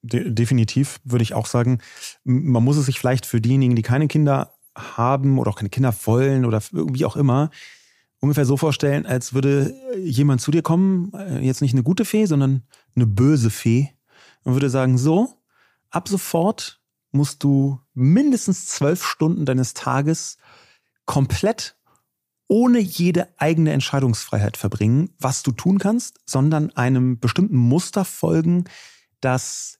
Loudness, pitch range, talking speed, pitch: -20 LUFS, 125-160 Hz, 145 wpm, 135 Hz